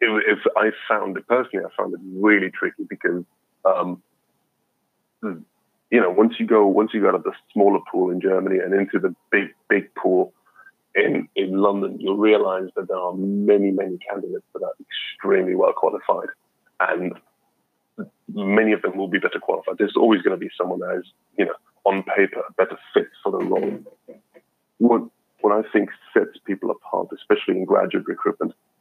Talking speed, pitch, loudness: 175 wpm, 105 Hz, -21 LUFS